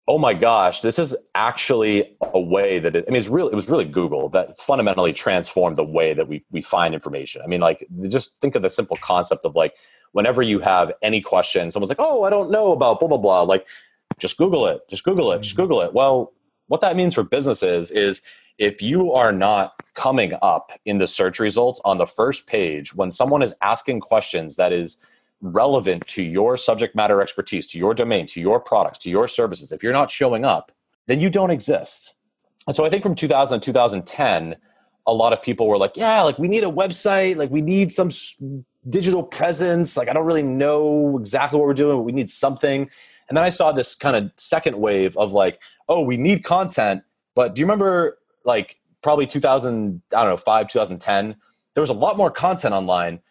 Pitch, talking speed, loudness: 150 Hz, 215 wpm, -19 LUFS